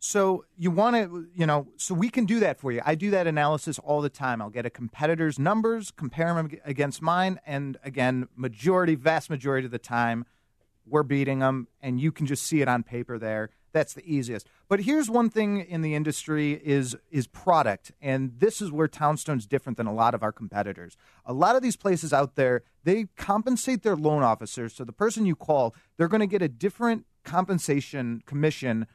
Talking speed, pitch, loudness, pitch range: 205 wpm, 150 Hz, -26 LUFS, 125-180 Hz